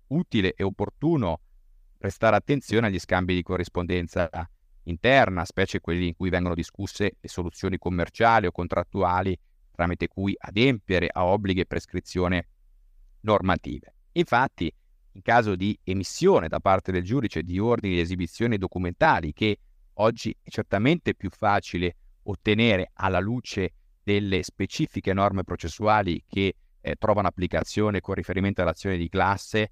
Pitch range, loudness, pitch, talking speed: 90-105 Hz, -25 LUFS, 95 Hz, 130 wpm